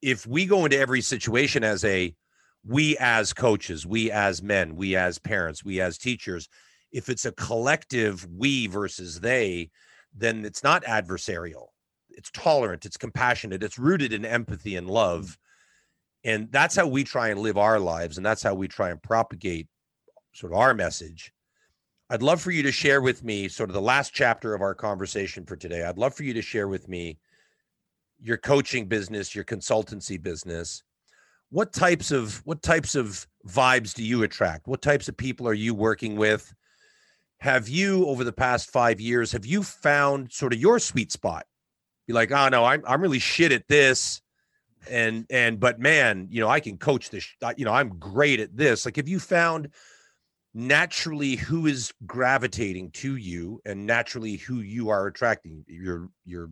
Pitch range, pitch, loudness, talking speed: 100-130 Hz, 115 Hz, -24 LUFS, 180 wpm